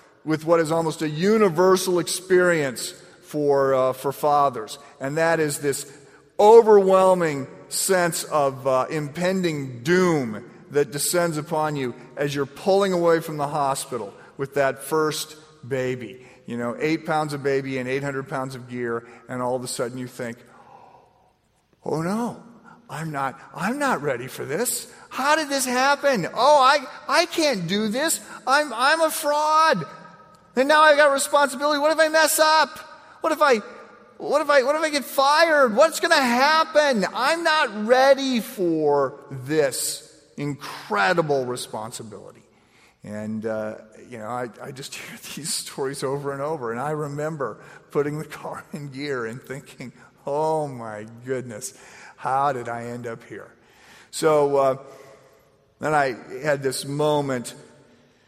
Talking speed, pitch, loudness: 150 wpm, 155 Hz, -22 LUFS